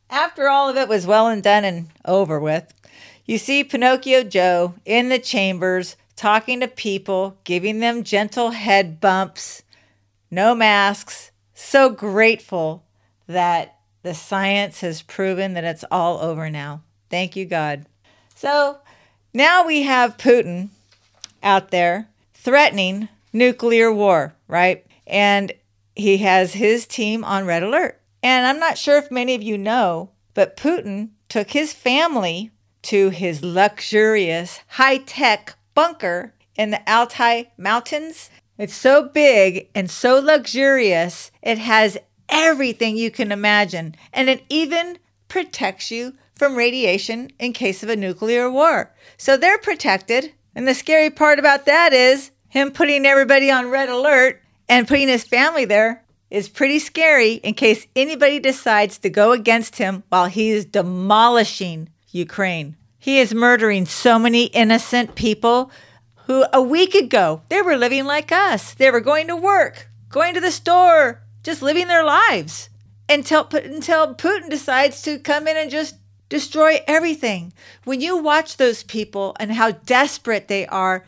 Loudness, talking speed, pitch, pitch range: -17 LUFS, 145 wpm, 230 Hz, 190-275 Hz